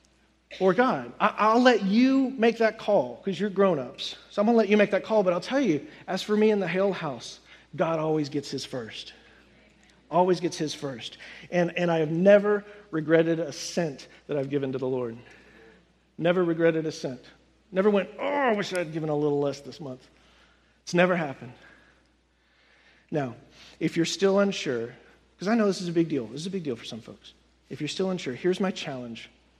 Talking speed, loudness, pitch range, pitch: 205 wpm, -26 LUFS, 150-205 Hz, 175 Hz